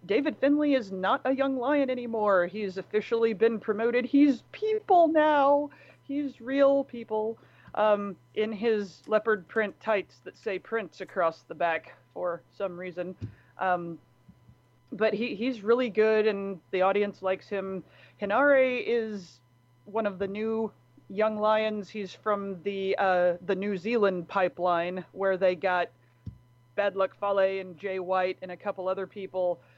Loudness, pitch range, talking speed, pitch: -28 LUFS, 180-225 Hz, 150 wpm, 200 Hz